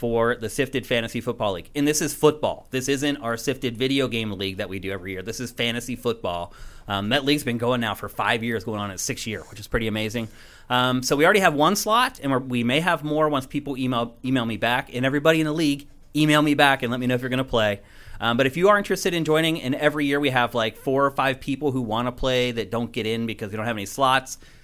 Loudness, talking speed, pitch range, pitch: -23 LUFS, 275 wpm, 115-140 Hz, 125 Hz